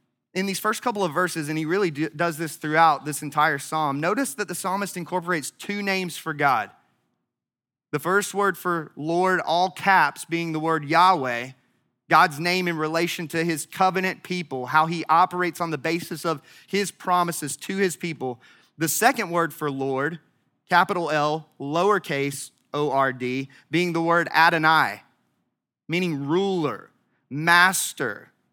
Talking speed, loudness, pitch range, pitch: 155 wpm, -23 LUFS, 150-180 Hz, 165 Hz